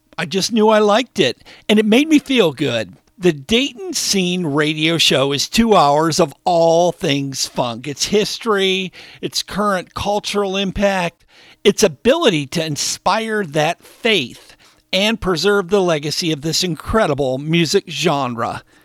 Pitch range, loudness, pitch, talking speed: 155-205 Hz, -16 LUFS, 180 Hz, 145 wpm